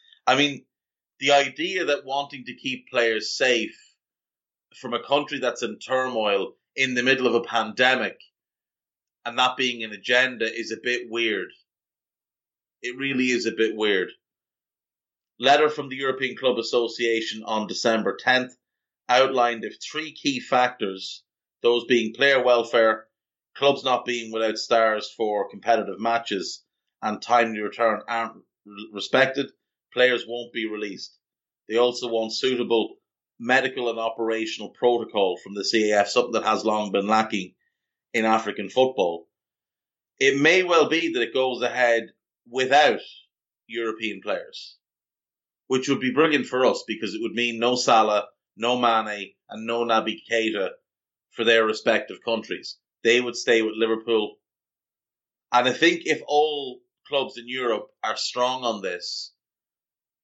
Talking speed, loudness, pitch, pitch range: 140 wpm, -23 LUFS, 120 Hz, 110-130 Hz